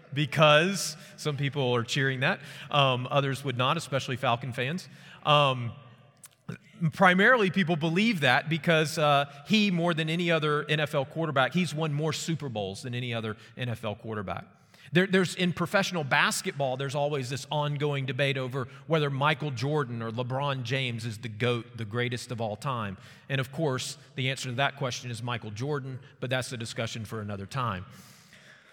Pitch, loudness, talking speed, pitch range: 140 Hz, -28 LUFS, 165 wpm, 125-155 Hz